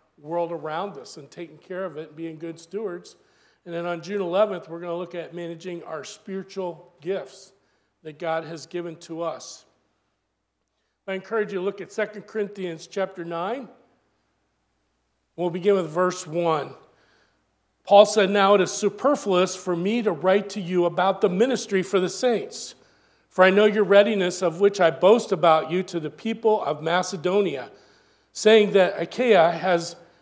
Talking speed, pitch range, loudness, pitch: 170 wpm, 170-205 Hz, -23 LUFS, 185 Hz